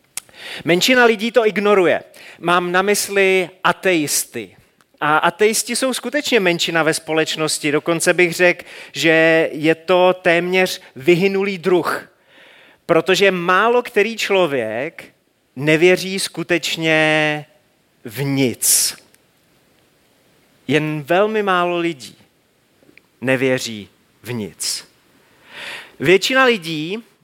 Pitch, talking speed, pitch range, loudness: 175 Hz, 90 wpm, 155-200 Hz, -16 LUFS